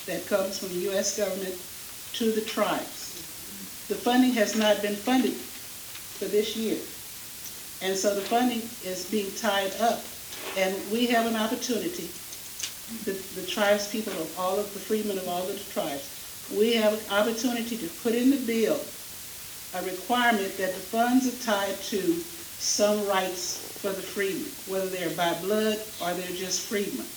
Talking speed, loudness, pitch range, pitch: 165 wpm, -28 LUFS, 190-225 Hz, 205 Hz